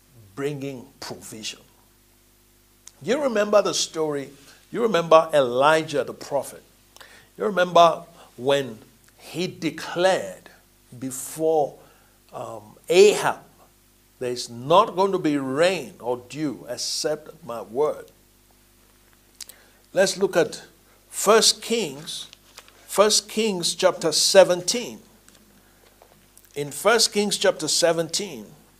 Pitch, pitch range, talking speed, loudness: 155 Hz, 120-190 Hz, 90 wpm, -22 LUFS